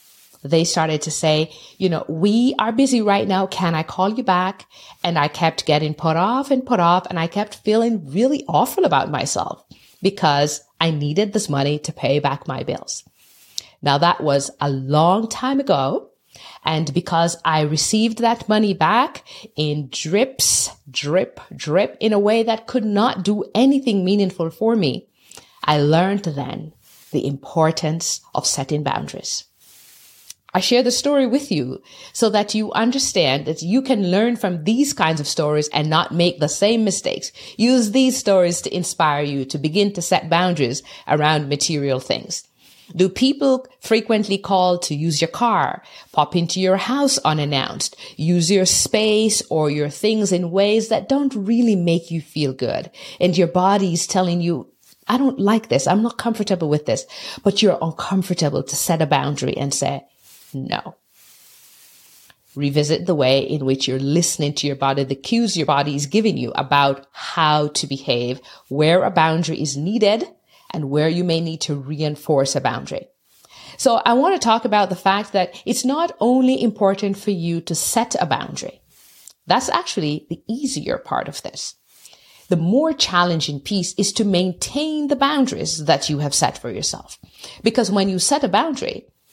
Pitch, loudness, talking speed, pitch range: 175 Hz, -19 LUFS, 170 wpm, 150-215 Hz